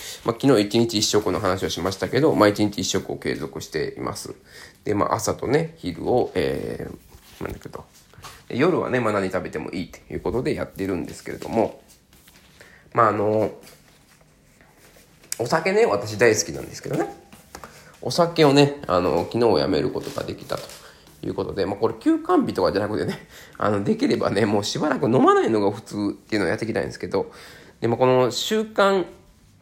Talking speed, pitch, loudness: 360 characters per minute, 125 Hz, -22 LUFS